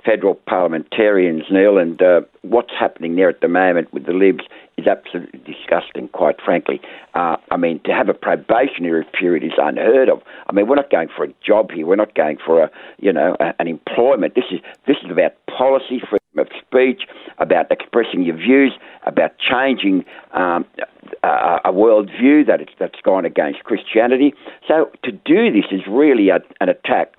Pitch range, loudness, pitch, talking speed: 95-135 Hz, -16 LUFS, 125 Hz, 185 wpm